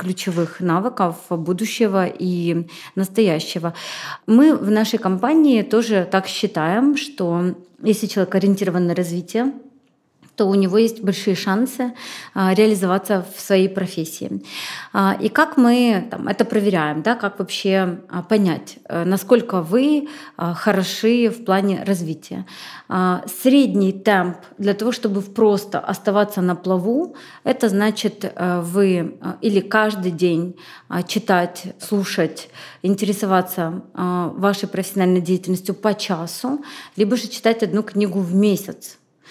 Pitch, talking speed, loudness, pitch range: 195 Hz, 115 wpm, -19 LUFS, 180-220 Hz